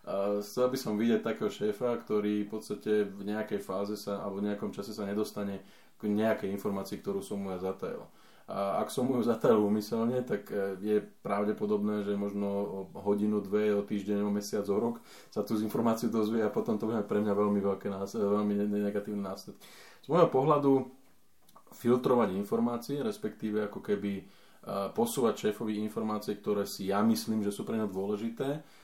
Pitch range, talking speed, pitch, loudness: 100-110 Hz, 175 wpm, 105 Hz, -32 LUFS